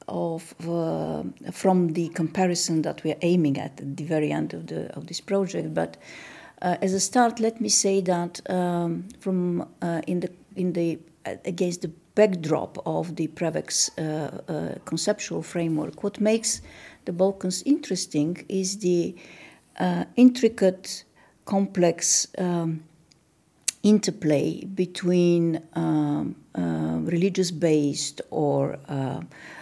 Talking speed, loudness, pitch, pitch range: 130 wpm, -25 LUFS, 170 Hz, 155-185 Hz